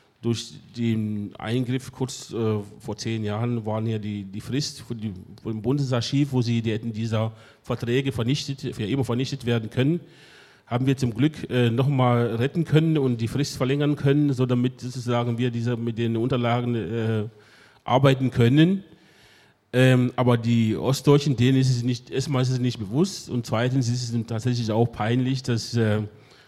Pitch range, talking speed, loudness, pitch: 115-135 Hz, 170 wpm, -24 LUFS, 125 Hz